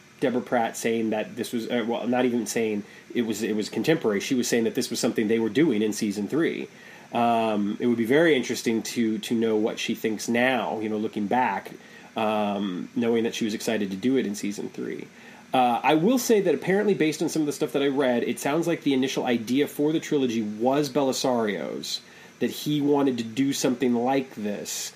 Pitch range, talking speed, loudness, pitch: 110-145 Hz, 220 wpm, -25 LUFS, 120 Hz